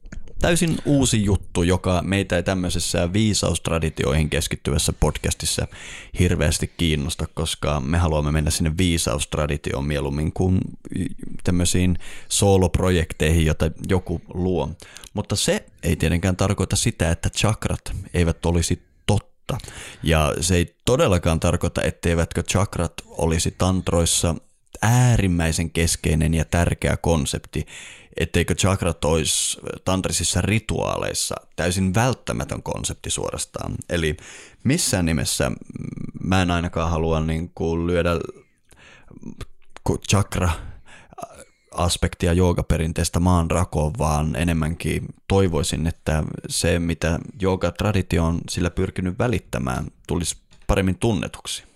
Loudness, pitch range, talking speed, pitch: -22 LUFS, 80-95 Hz, 100 wpm, 85 Hz